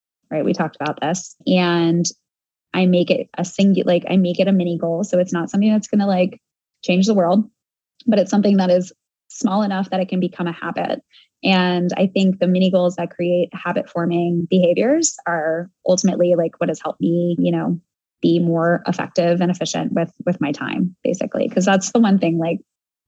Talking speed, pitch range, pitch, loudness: 205 wpm, 170-190 Hz, 180 Hz, -19 LUFS